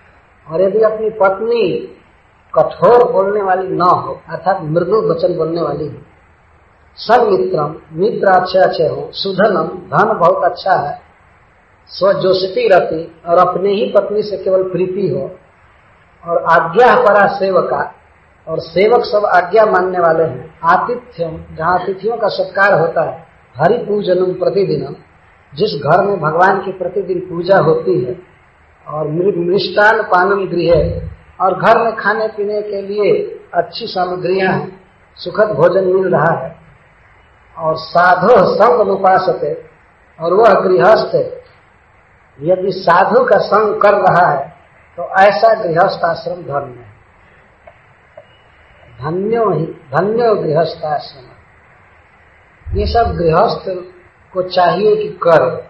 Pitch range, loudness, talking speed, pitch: 165-205 Hz, -13 LUFS, 125 wpm, 185 Hz